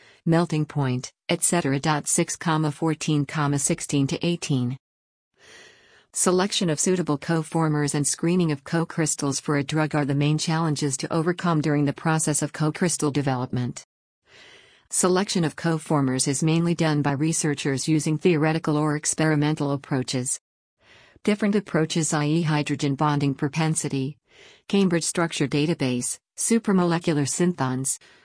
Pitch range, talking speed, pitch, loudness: 145-165 Hz, 120 wpm, 155 Hz, -23 LUFS